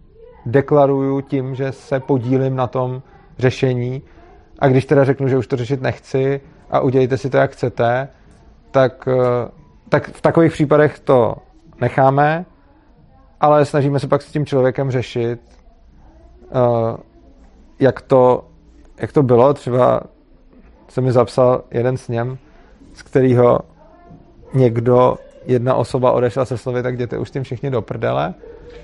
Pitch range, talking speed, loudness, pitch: 125-140 Hz, 135 wpm, -17 LUFS, 130 Hz